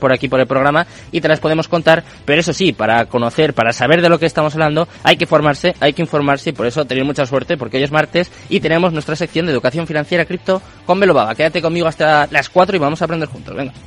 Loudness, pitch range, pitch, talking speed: -15 LUFS, 140-170 Hz, 155 Hz, 255 wpm